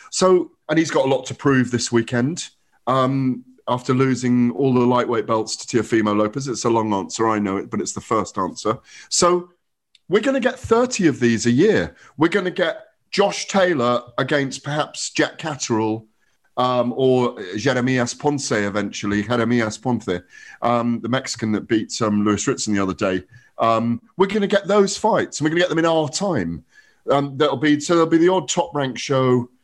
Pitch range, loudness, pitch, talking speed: 115-160 Hz, -20 LUFS, 130 Hz, 195 wpm